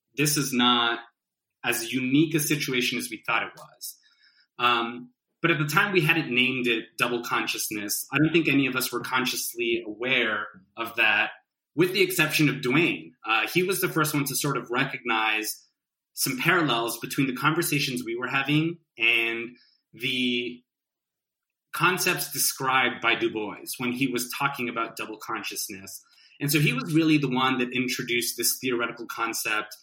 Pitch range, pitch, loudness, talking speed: 120-150 Hz, 125 Hz, -25 LUFS, 165 wpm